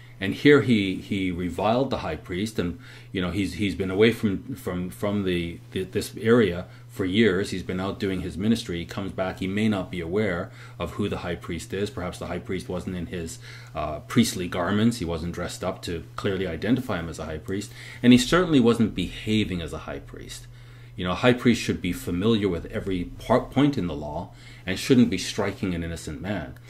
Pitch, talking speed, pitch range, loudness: 100 Hz, 220 wpm, 90-120 Hz, -25 LUFS